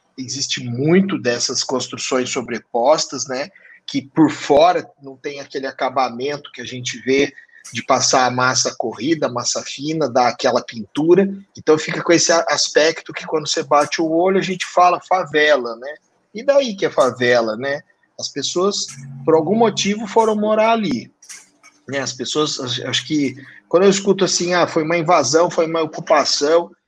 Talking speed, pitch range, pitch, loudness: 165 wpm, 135-180 Hz, 155 Hz, -18 LUFS